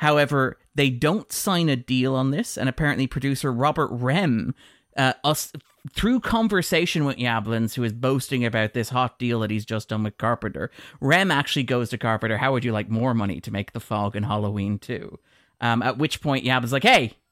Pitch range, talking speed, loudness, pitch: 115-145 Hz, 200 wpm, -23 LUFS, 130 Hz